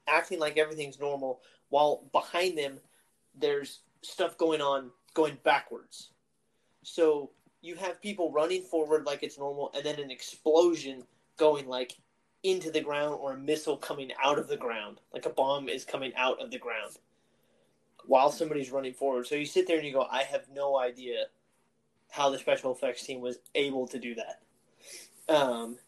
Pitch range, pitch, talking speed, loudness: 135-165 Hz, 145 Hz, 170 wpm, -31 LUFS